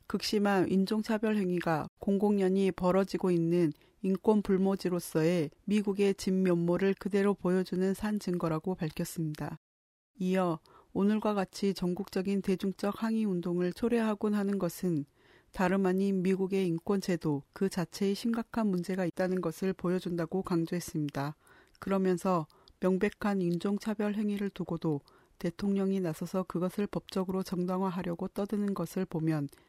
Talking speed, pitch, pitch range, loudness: 325 characters per minute, 190 Hz, 175-200 Hz, -31 LUFS